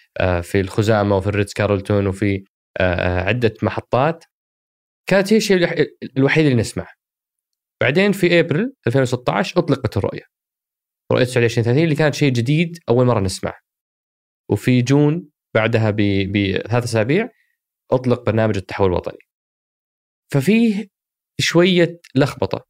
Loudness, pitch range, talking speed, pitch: -18 LUFS, 105-160 Hz, 110 wpm, 120 Hz